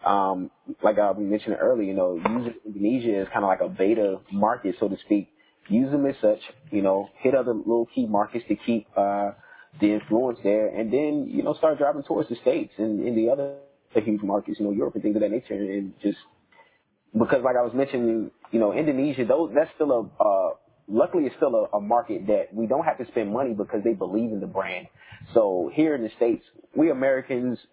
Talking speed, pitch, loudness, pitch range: 215 wpm, 115 Hz, -25 LUFS, 105-130 Hz